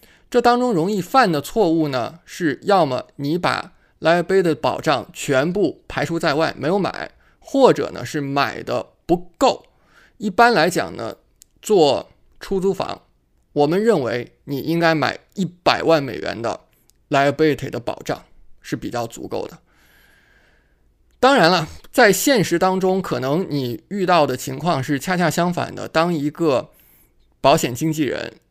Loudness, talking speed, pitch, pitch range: -19 LUFS, 240 characters per minute, 160 Hz, 135-180 Hz